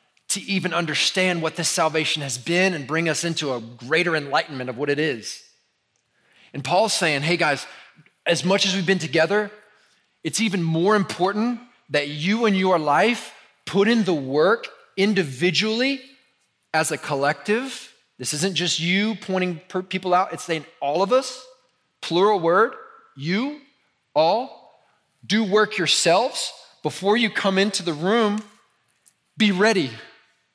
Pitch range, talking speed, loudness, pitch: 160-215 Hz, 145 wpm, -21 LUFS, 185 Hz